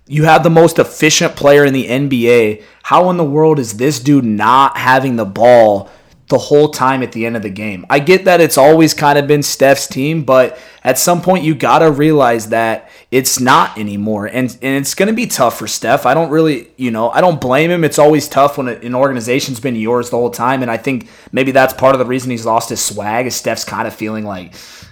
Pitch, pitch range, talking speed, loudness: 130 Hz, 120-150 Hz, 235 wpm, -12 LUFS